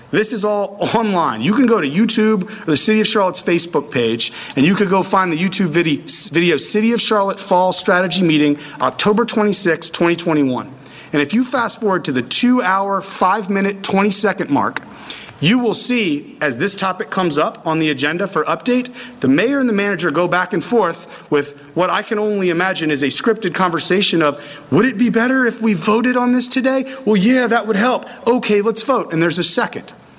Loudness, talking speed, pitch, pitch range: -16 LUFS, 200 wpm, 195 Hz, 170-225 Hz